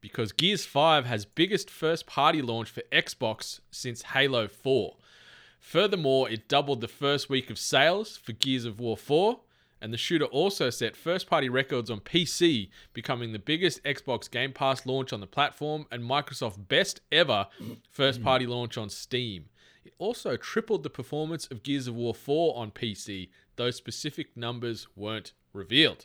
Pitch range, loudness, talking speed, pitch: 115-145 Hz, -28 LUFS, 165 wpm, 130 Hz